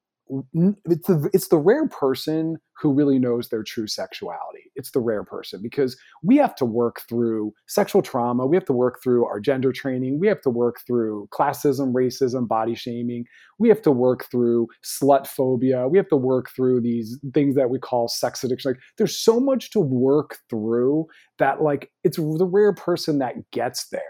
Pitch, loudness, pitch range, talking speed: 130 Hz, -22 LUFS, 120-160 Hz, 190 wpm